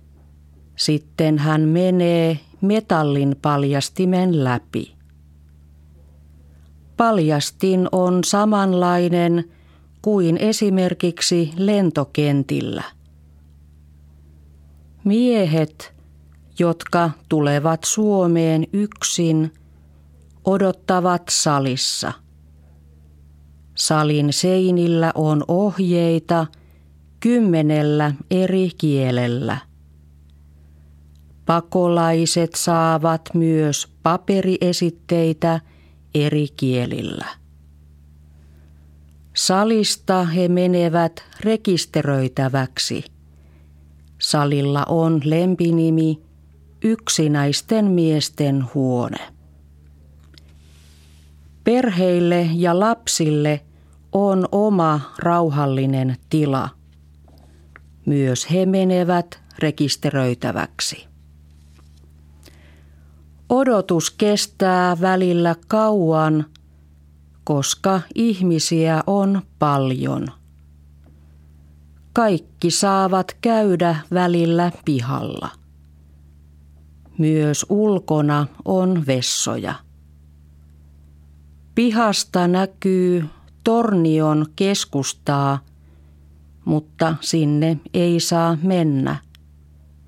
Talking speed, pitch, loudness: 55 wpm, 150 Hz, -19 LUFS